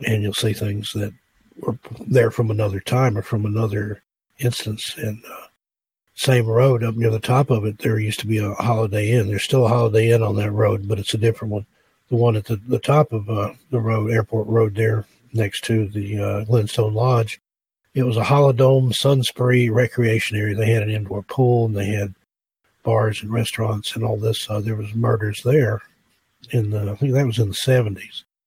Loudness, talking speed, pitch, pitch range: -20 LUFS, 205 wpm, 110 Hz, 105-120 Hz